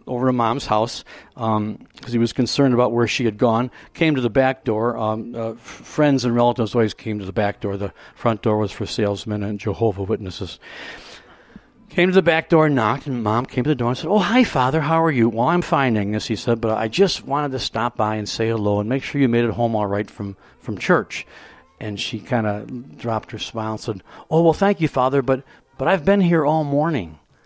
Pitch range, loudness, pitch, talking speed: 110-140 Hz, -20 LUFS, 120 Hz, 240 wpm